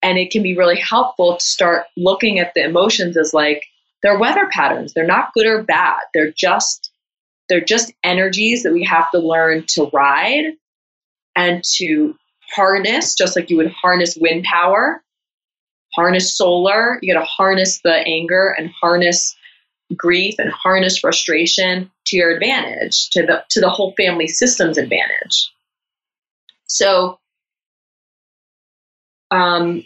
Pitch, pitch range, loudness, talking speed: 180 Hz, 170-195 Hz, -15 LUFS, 145 wpm